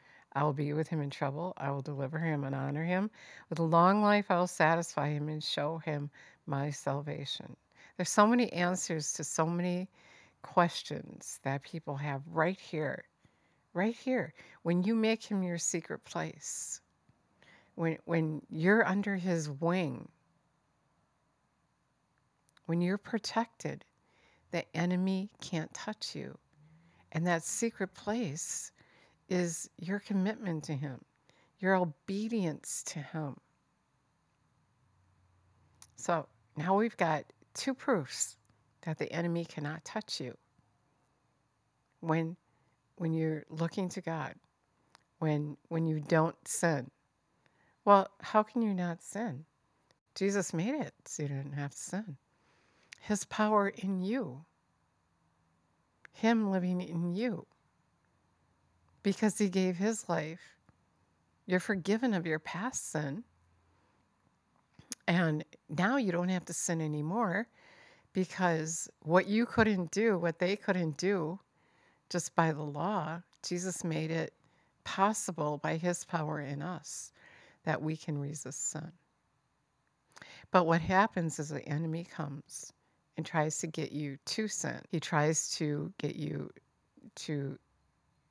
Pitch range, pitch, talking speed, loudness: 150-190 Hz, 165 Hz, 130 wpm, -34 LUFS